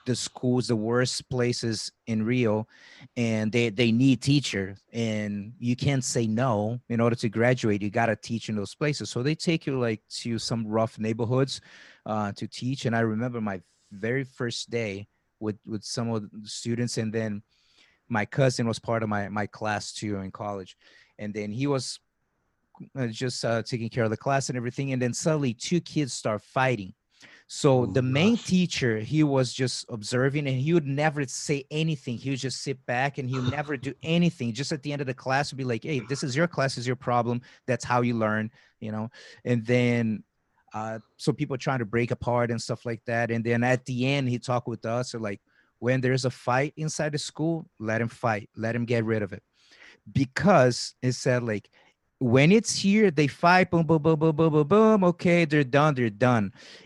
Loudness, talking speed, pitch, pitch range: -26 LUFS, 210 wpm, 125 Hz, 115-140 Hz